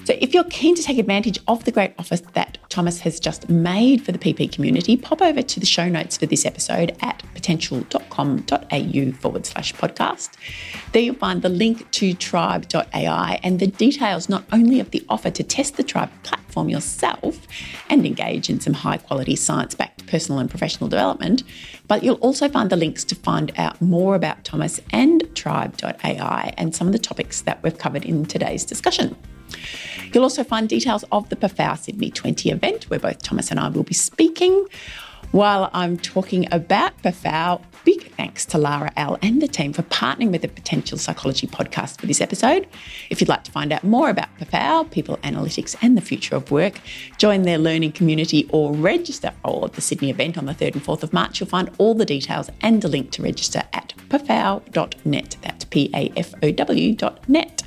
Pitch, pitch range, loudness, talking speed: 195 Hz, 170-255 Hz, -20 LUFS, 185 wpm